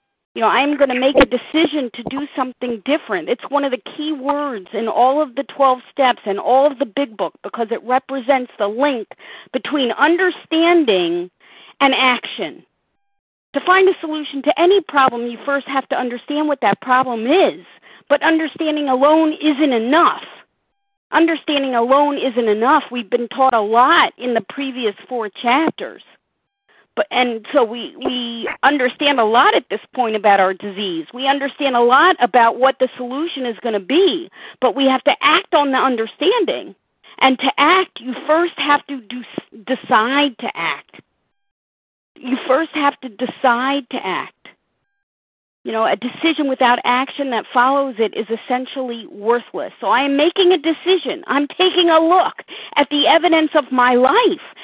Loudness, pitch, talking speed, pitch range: -17 LUFS, 270 Hz, 170 wpm, 245-305 Hz